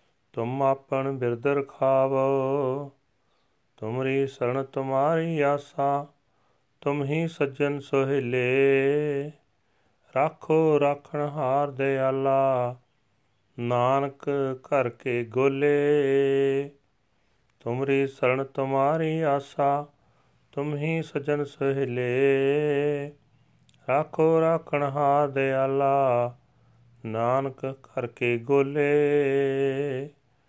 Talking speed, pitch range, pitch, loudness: 65 wpm, 130-145 Hz, 135 Hz, -25 LUFS